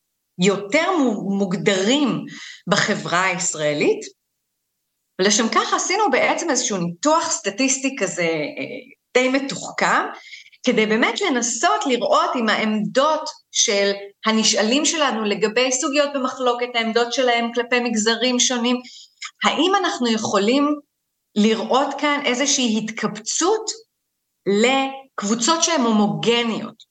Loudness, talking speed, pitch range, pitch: -19 LUFS, 90 wpm, 215-290 Hz, 245 Hz